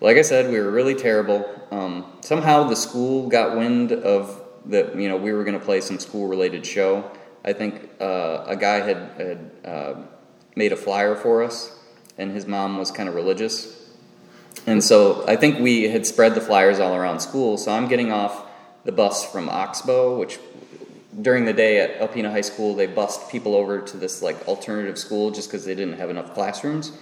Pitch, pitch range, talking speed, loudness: 105 Hz, 100-125 Hz, 200 wpm, -21 LUFS